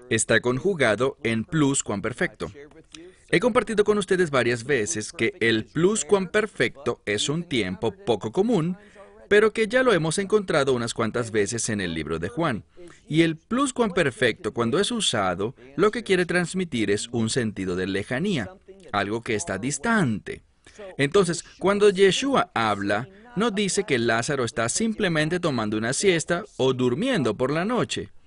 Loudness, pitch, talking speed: -24 LUFS, 150 Hz, 160 wpm